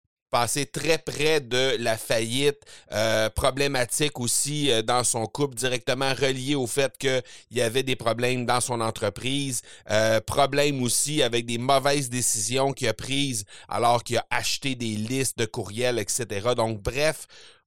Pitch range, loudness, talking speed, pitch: 115-140 Hz, -25 LUFS, 155 wpm, 125 Hz